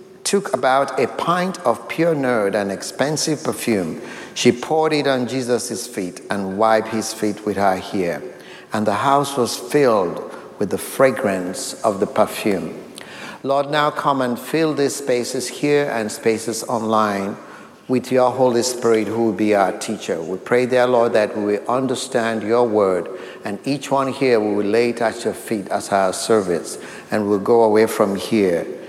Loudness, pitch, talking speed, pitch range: -19 LUFS, 120 Hz, 170 wpm, 110-135 Hz